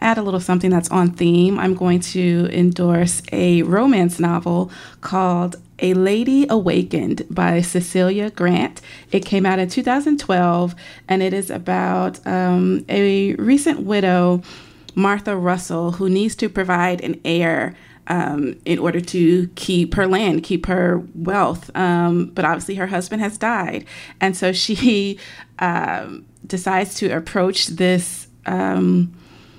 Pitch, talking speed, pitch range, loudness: 180 Hz, 140 wpm, 175-195 Hz, -18 LUFS